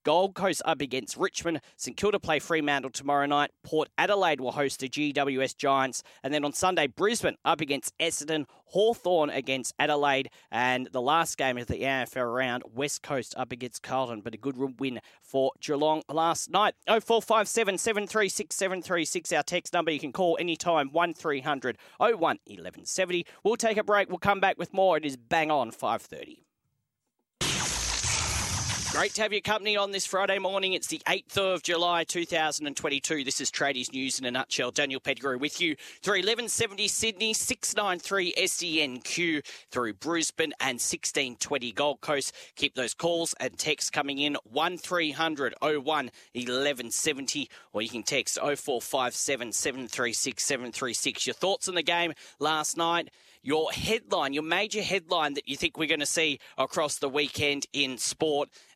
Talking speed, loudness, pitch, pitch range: 170 wpm, -28 LUFS, 155 Hz, 135-180 Hz